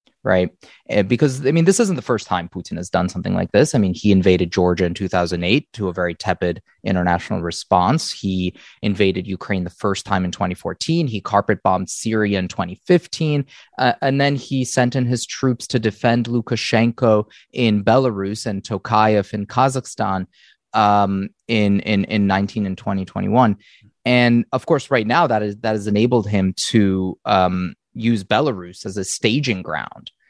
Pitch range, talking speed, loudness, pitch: 95-120 Hz, 170 wpm, -19 LUFS, 105 Hz